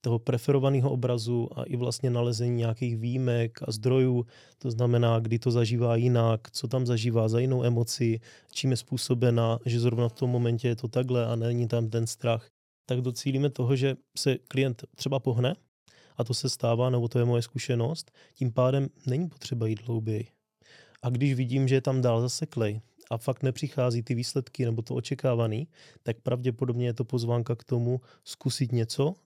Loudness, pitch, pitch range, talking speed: -28 LUFS, 125 Hz, 120-130 Hz, 180 wpm